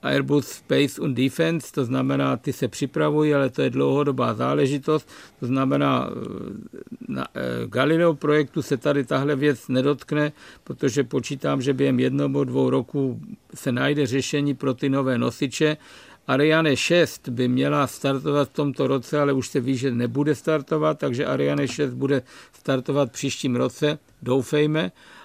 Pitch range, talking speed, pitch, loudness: 130-150 Hz, 145 wpm, 140 Hz, -23 LUFS